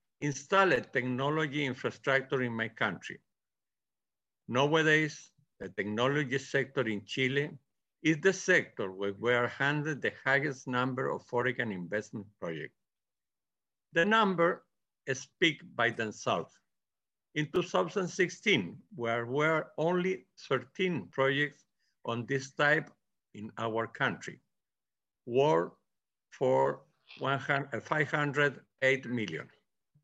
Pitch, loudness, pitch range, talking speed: 140 Hz, -31 LUFS, 120-155 Hz, 100 wpm